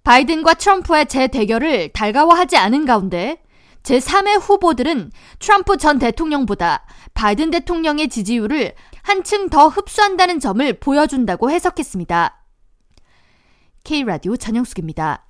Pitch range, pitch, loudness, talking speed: 235-340 Hz, 295 Hz, -16 LUFS, 310 characters per minute